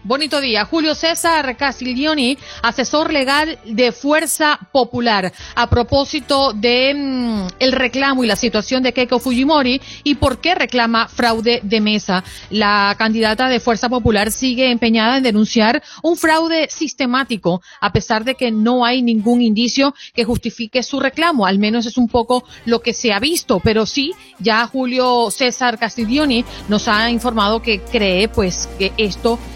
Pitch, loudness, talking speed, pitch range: 245 Hz, -16 LUFS, 155 wpm, 225-275 Hz